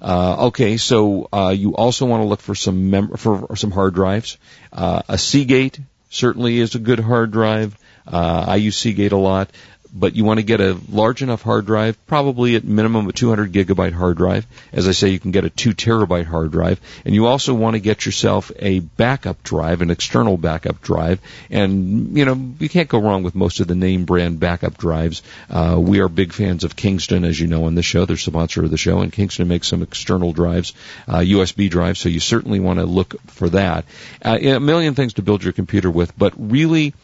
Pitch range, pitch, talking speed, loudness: 90-115 Hz, 100 Hz, 220 wpm, -17 LUFS